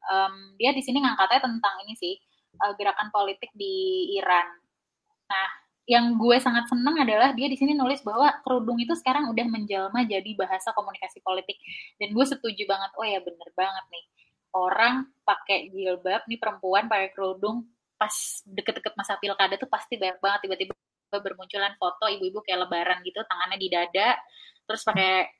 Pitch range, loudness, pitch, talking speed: 190-240 Hz, -26 LUFS, 205 Hz, 160 wpm